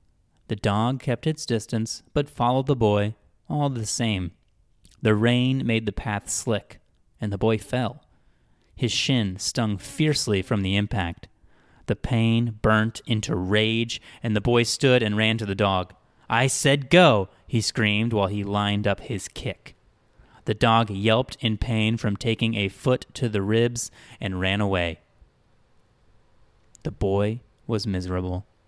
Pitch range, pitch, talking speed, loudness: 100-120 Hz, 110 Hz, 155 wpm, -24 LUFS